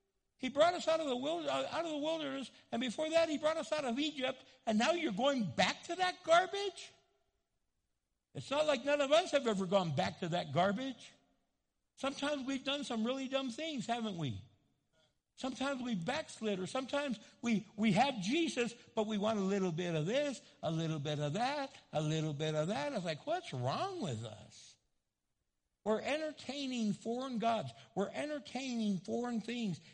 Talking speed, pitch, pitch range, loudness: 180 wpm, 245 Hz, 195-290 Hz, -36 LUFS